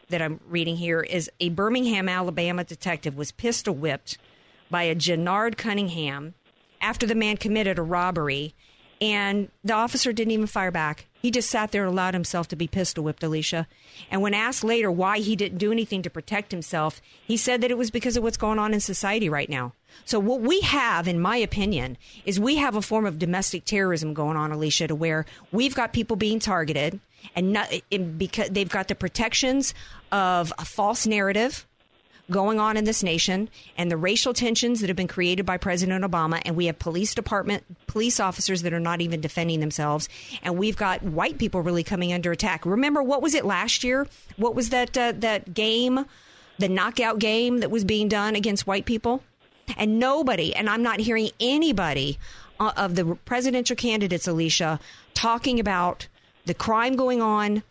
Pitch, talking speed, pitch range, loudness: 195 Hz, 190 wpm, 170-225 Hz, -24 LUFS